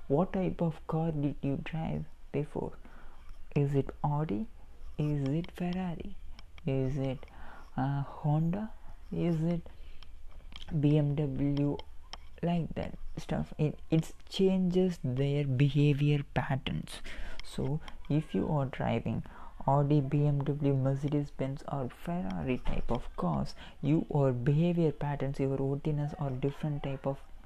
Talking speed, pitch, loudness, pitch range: 115 wpm, 145 Hz, -32 LUFS, 135-160 Hz